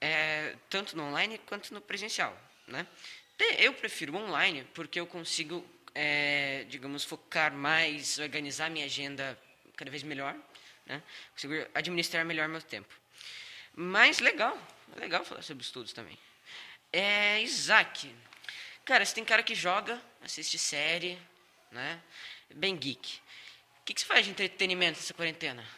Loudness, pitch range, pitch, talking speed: -30 LUFS, 145-190 Hz, 165 Hz, 135 wpm